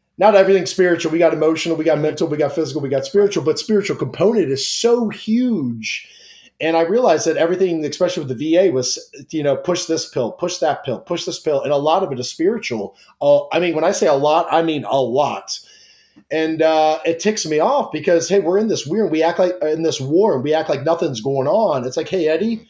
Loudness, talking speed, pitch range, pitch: -18 LUFS, 240 wpm, 155-185 Hz, 165 Hz